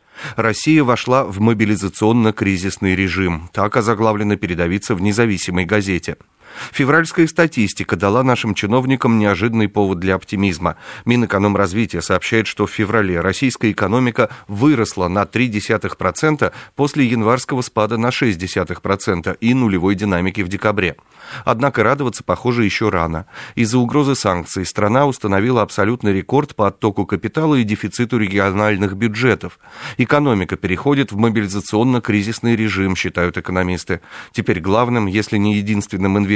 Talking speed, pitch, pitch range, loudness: 120 wpm, 105 Hz, 95-120 Hz, -17 LUFS